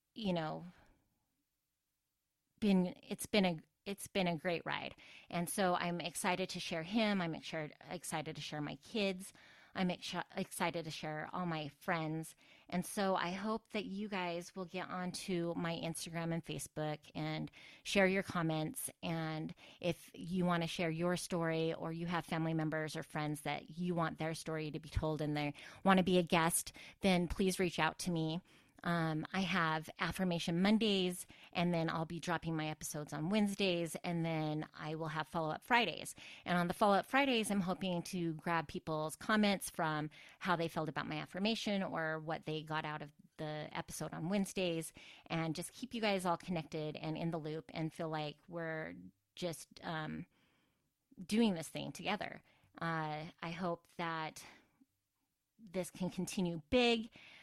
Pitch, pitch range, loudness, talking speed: 170 Hz, 155-185 Hz, -38 LUFS, 175 wpm